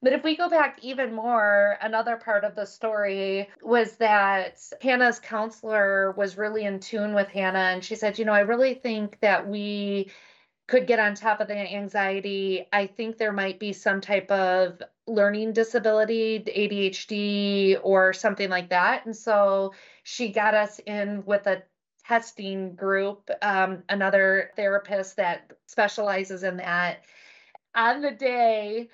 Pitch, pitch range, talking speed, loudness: 205 Hz, 195-225 Hz, 155 wpm, -25 LUFS